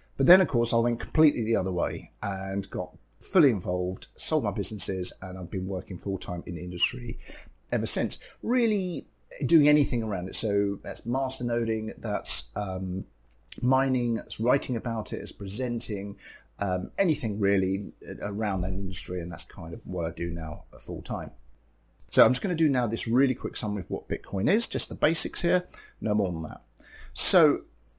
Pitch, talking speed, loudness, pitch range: 100 Hz, 180 wpm, -27 LUFS, 90-120 Hz